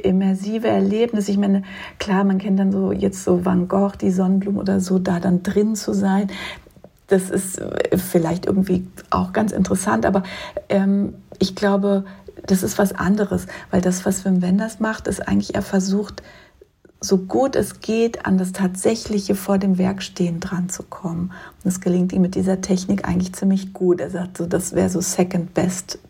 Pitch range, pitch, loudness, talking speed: 185-200 Hz, 190 Hz, -20 LUFS, 175 wpm